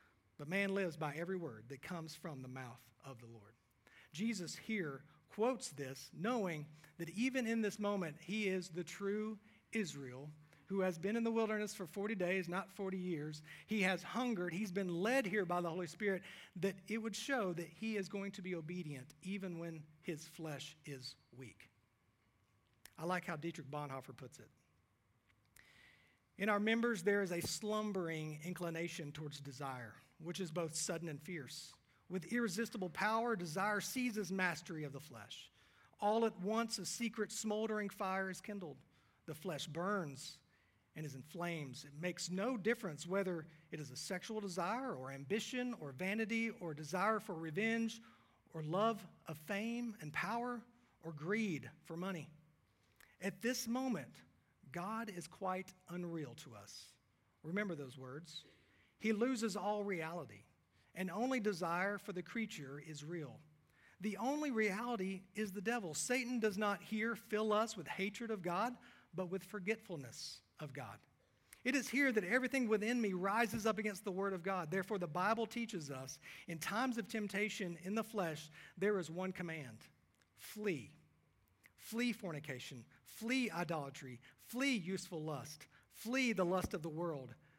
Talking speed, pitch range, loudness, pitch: 160 wpm, 150-210 Hz, -41 LUFS, 180 Hz